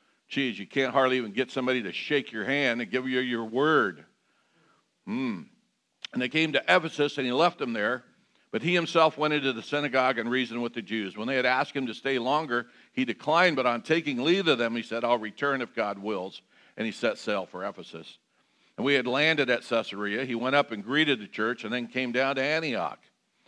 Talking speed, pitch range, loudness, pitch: 220 wpm, 115-145 Hz, -27 LUFS, 130 Hz